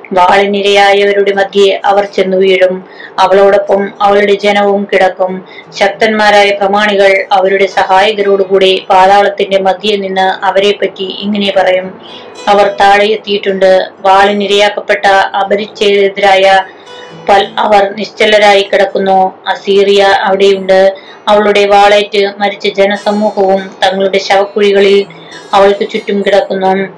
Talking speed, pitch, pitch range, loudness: 85 wpm, 200 Hz, 195-205 Hz, -8 LUFS